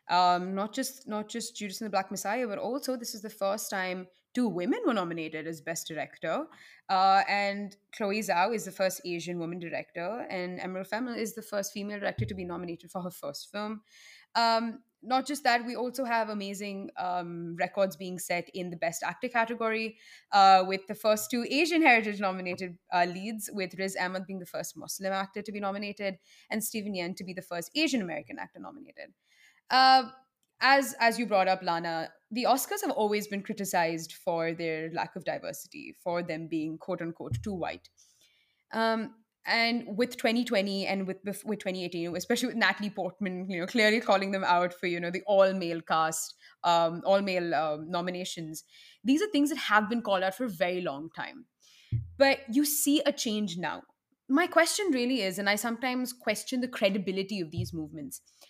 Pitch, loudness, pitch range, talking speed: 200 Hz, -30 LUFS, 180-230 Hz, 190 wpm